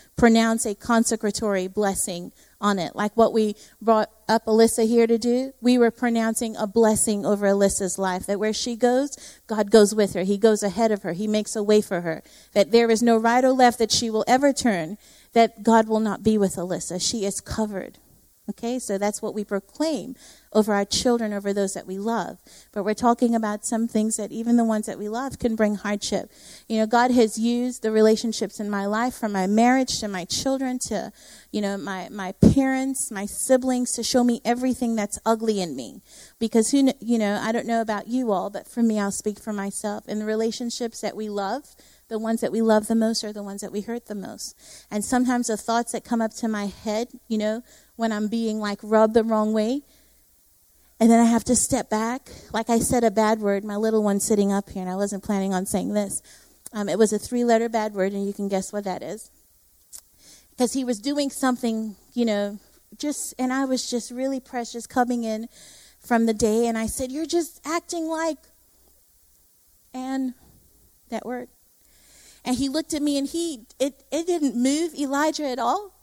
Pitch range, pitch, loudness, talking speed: 210-245 Hz, 225 Hz, -23 LUFS, 210 wpm